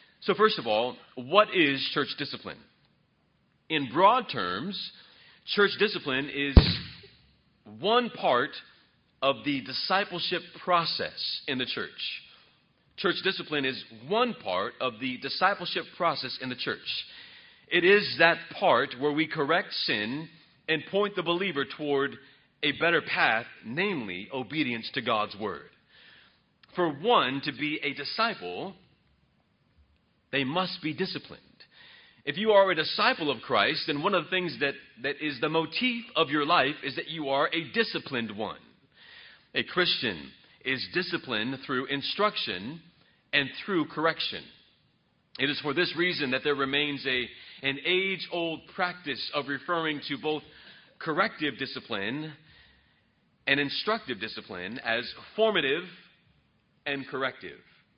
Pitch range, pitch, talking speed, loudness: 135-180 Hz, 155 Hz, 130 wpm, -28 LUFS